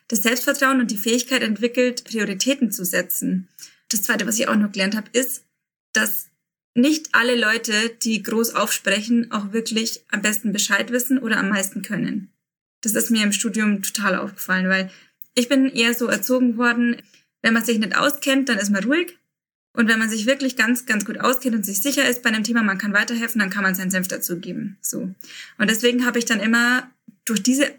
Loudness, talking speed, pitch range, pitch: -20 LUFS, 200 wpm, 210-250 Hz, 230 Hz